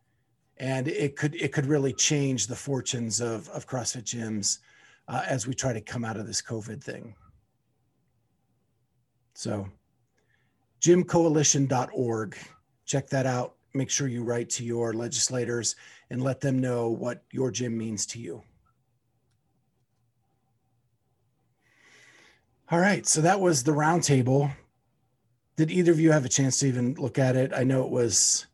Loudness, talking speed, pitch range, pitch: -26 LUFS, 145 wpm, 115-135 Hz, 125 Hz